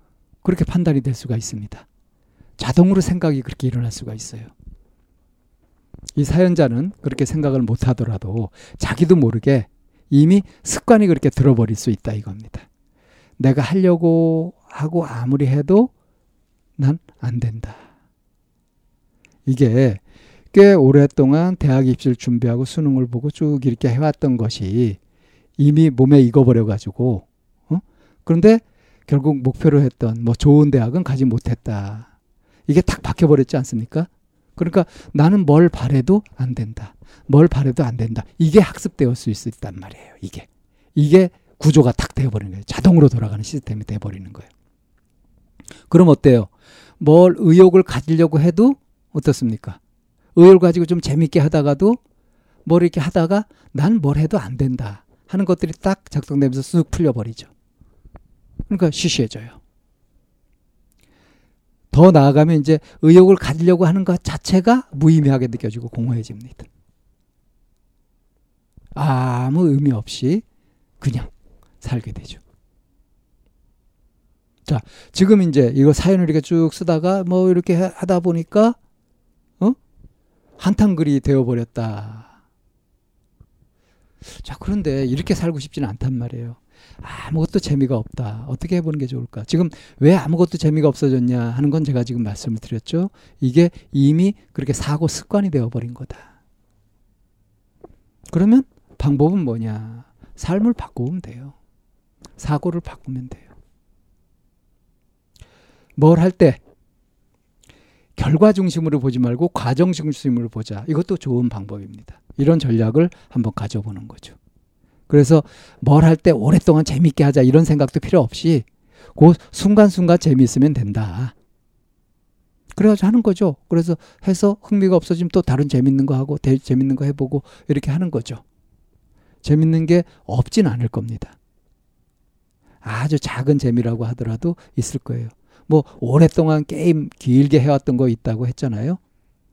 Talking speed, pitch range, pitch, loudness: 285 characters per minute, 115-165 Hz, 140 Hz, -17 LUFS